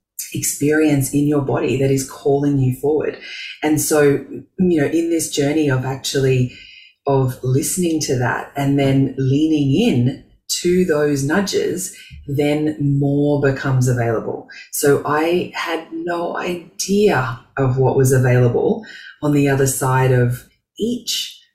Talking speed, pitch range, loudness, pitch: 135 wpm, 135-155 Hz, -18 LUFS, 140 Hz